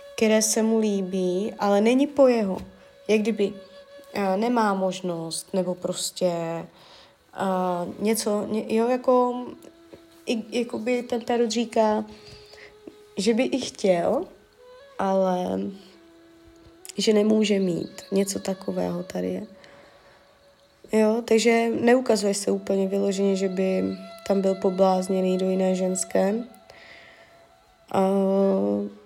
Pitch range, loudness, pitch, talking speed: 185-235 Hz, -24 LUFS, 200 Hz, 110 wpm